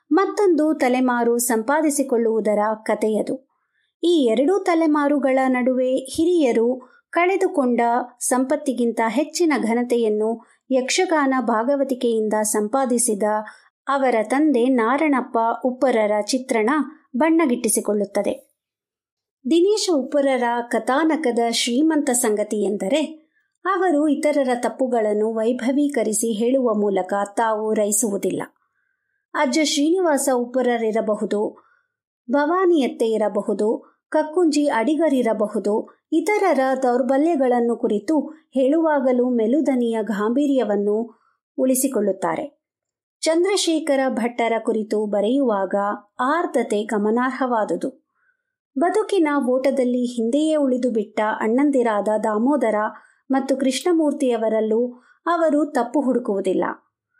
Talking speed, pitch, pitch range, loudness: 70 wpm, 255 Hz, 225-300 Hz, -20 LUFS